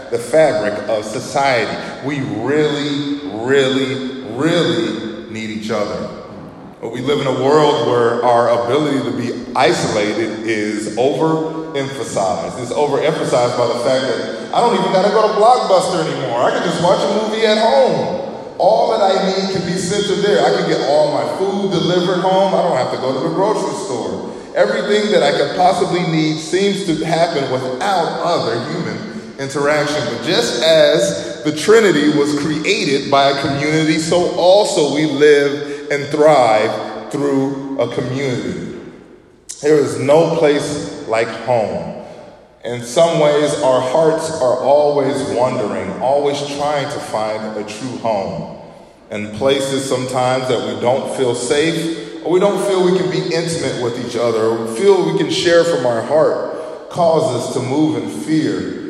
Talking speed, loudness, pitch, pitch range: 160 wpm, -16 LUFS, 145 Hz, 130-165 Hz